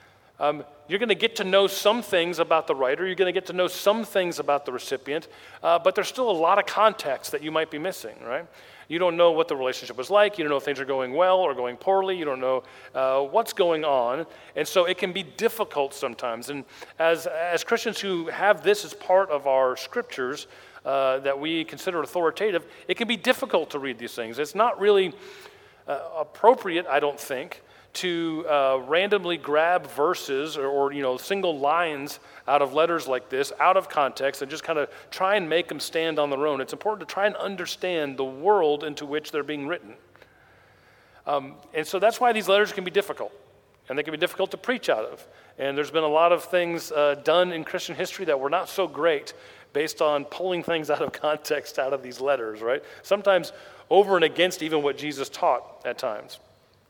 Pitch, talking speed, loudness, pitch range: 165 Hz, 215 wpm, -25 LUFS, 145-195 Hz